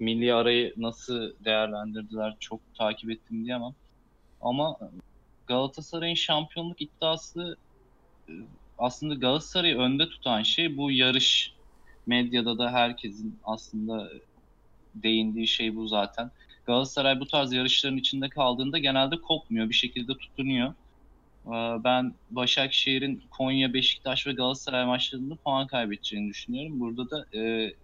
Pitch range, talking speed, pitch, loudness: 115-135 Hz, 110 wpm, 125 Hz, -27 LUFS